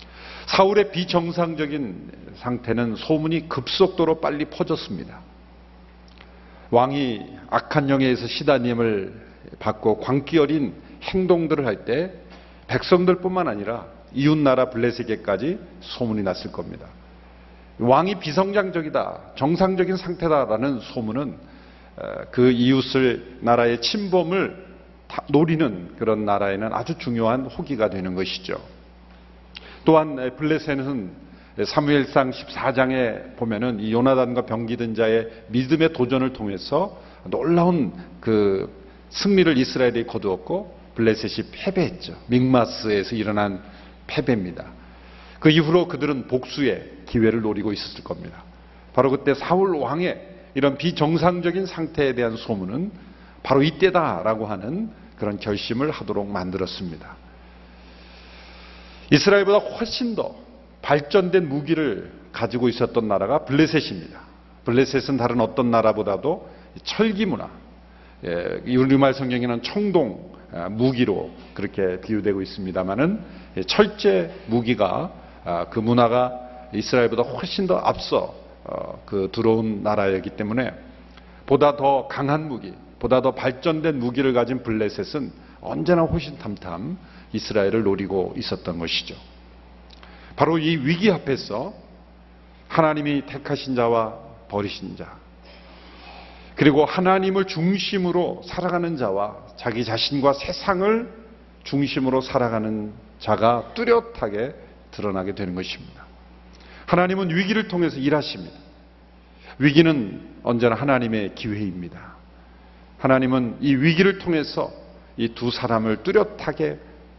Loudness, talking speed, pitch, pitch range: -22 LUFS, 275 characters per minute, 125 Hz, 100-160 Hz